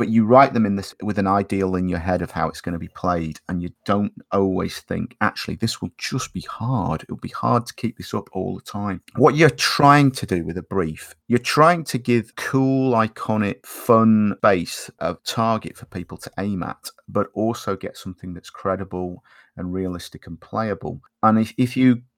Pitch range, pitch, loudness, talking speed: 90-120 Hz, 100 Hz, -21 LUFS, 210 wpm